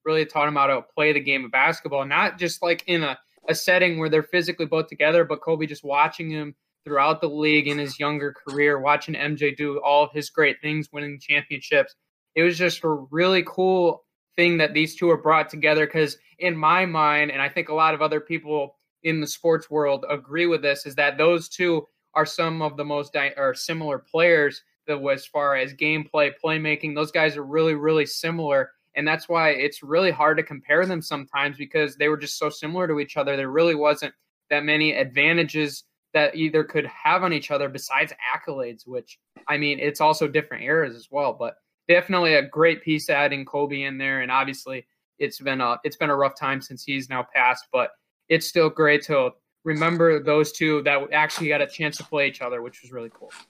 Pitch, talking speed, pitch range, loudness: 150 Hz, 210 wpm, 145-160 Hz, -22 LUFS